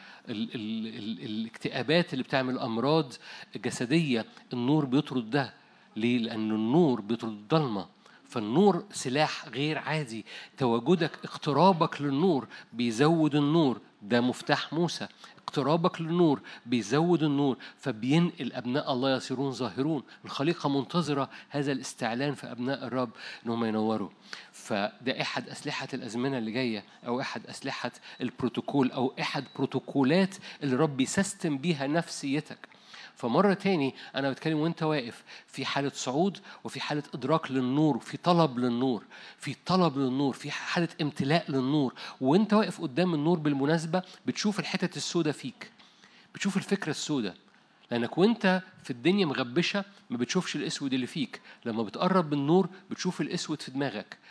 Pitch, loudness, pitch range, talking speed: 145 Hz, -29 LUFS, 130-170 Hz, 130 wpm